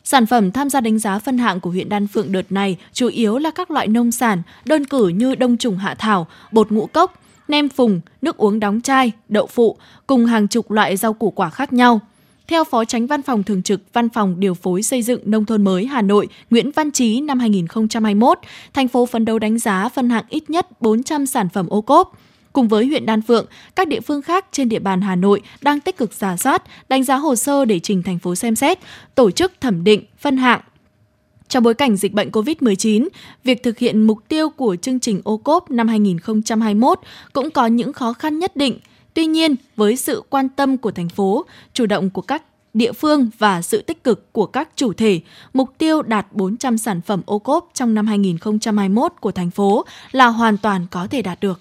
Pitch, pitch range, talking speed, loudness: 225 Hz, 205-265 Hz, 220 wpm, -17 LUFS